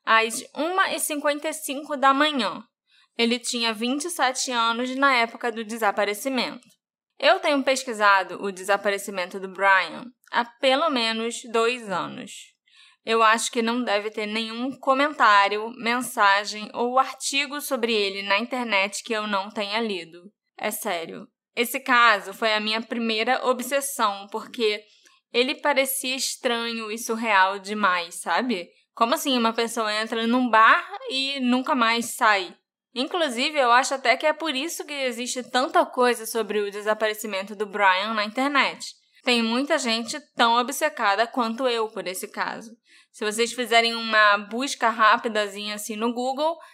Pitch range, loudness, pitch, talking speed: 215-265 Hz, -23 LUFS, 235 Hz, 140 wpm